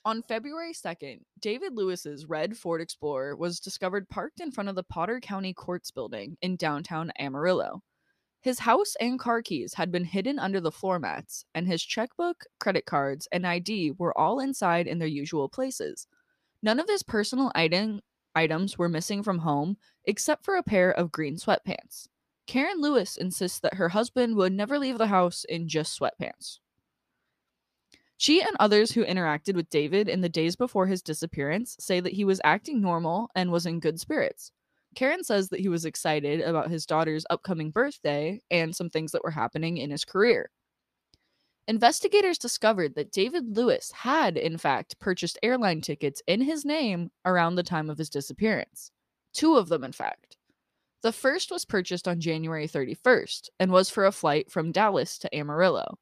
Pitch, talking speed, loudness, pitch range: 185 Hz, 175 wpm, -27 LUFS, 165-230 Hz